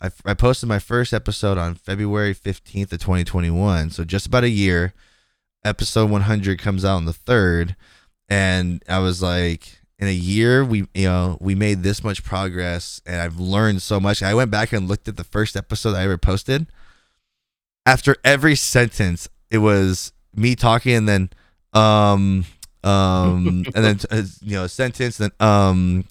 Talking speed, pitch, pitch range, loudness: 170 wpm, 100 Hz, 90-110 Hz, -19 LUFS